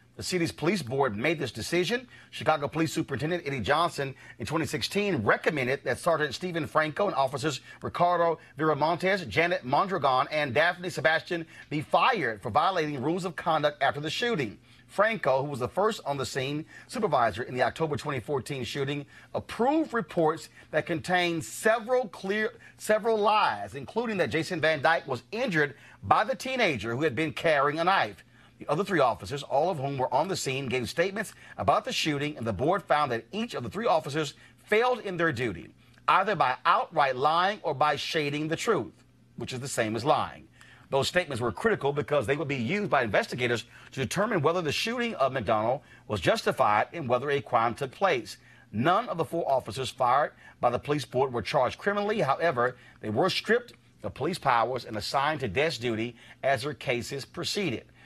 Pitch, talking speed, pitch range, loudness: 150 Hz, 180 wpm, 130-175 Hz, -28 LUFS